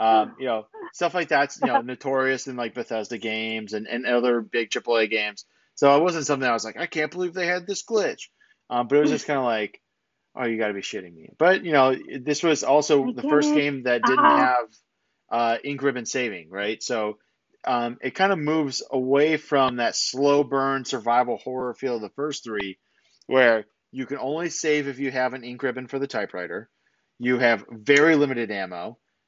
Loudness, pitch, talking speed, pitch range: -23 LUFS, 130 Hz, 210 wpm, 120-150 Hz